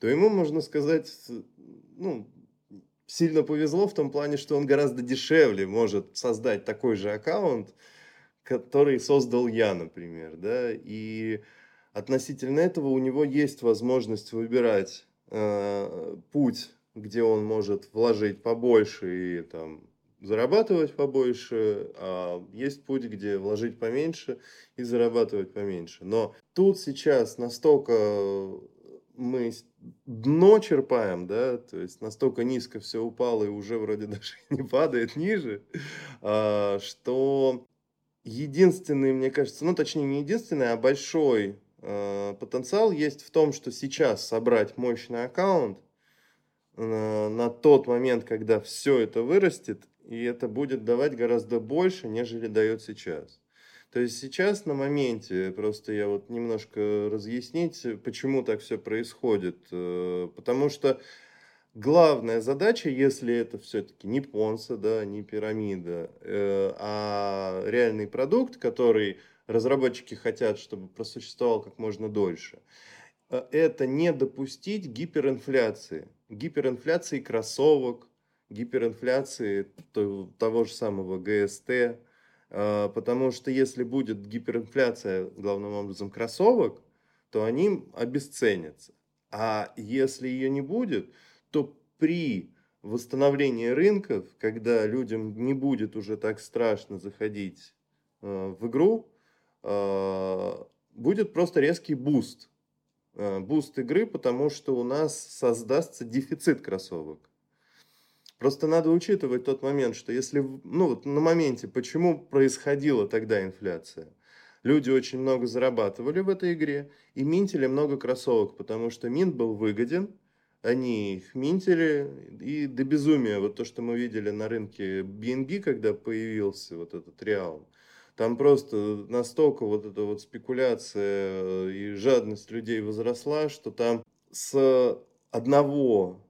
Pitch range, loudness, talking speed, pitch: 105-140 Hz, -27 LUFS, 115 wpm, 120 Hz